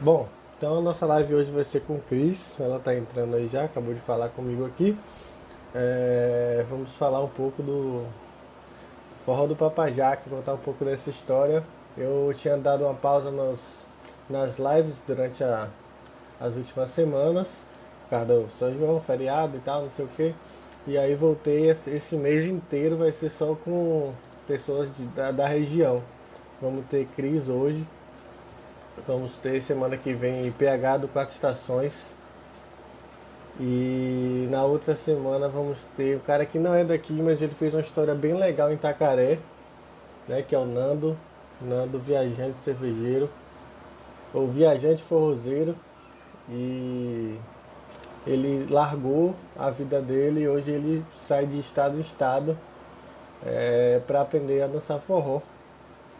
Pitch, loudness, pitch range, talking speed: 140 Hz, -26 LUFS, 130-155 Hz, 150 wpm